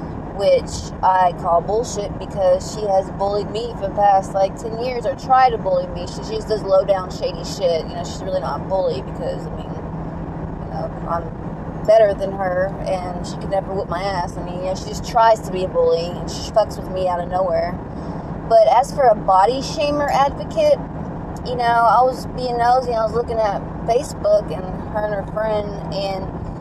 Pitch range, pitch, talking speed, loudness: 185-230 Hz, 195 Hz, 210 wpm, -20 LUFS